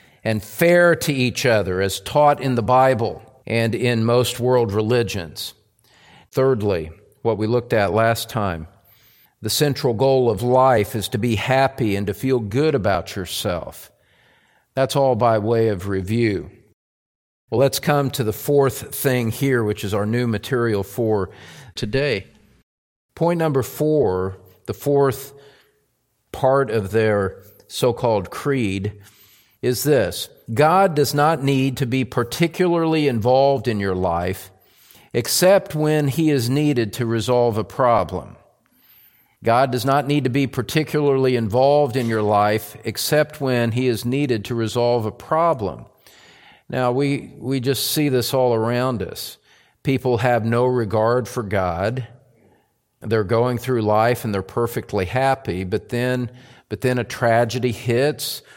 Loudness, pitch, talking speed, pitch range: -20 LUFS, 120 Hz, 145 wpm, 110-135 Hz